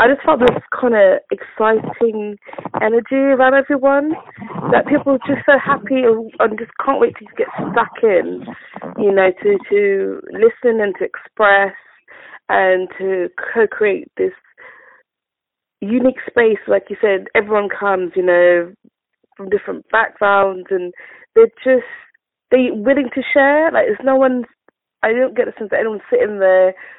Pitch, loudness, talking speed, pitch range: 250 Hz, -15 LUFS, 155 wpm, 205-310 Hz